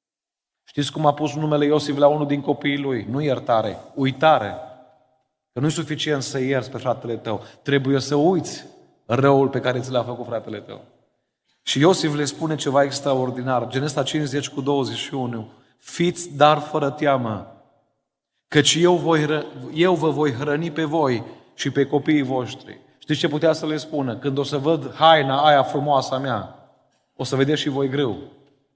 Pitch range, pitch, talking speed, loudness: 130-150 Hz, 140 Hz, 170 wpm, -21 LUFS